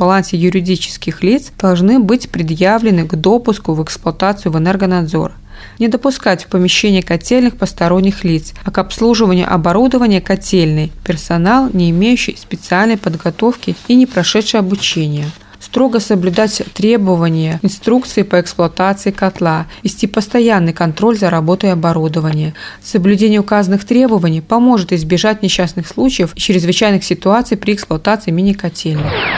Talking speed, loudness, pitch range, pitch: 120 wpm, -13 LUFS, 175-220 Hz, 190 Hz